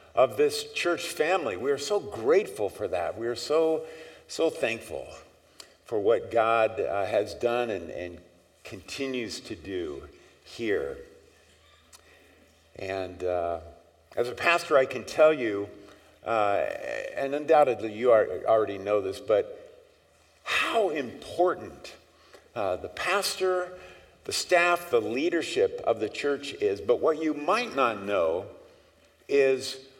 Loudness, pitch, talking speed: -27 LUFS, 160 Hz, 130 wpm